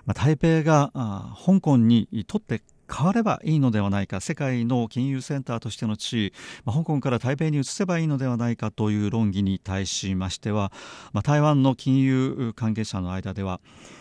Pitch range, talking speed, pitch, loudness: 105-140 Hz, 335 characters per minute, 120 Hz, -24 LUFS